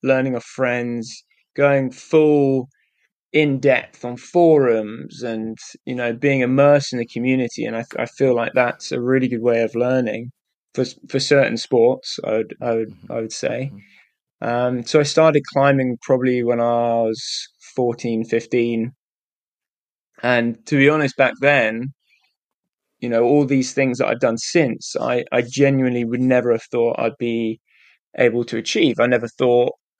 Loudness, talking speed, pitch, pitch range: -19 LUFS, 165 wpm, 125 Hz, 115-135 Hz